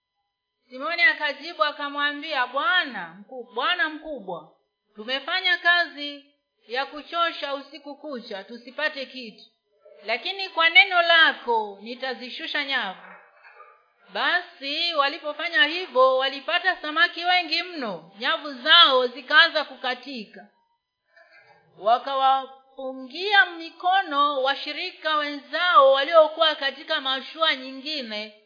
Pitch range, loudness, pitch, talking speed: 255-330 Hz, -22 LUFS, 285 Hz, 80 wpm